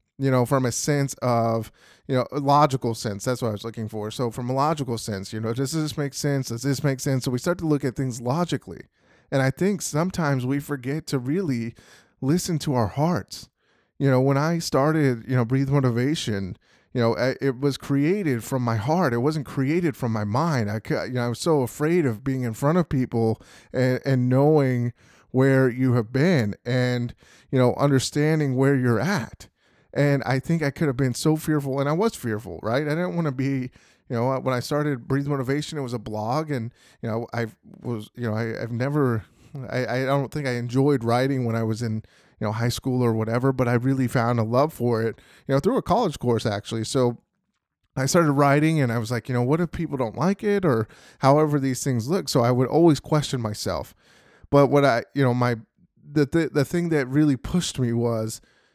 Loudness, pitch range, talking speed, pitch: -24 LUFS, 120-145 Hz, 220 wpm, 130 Hz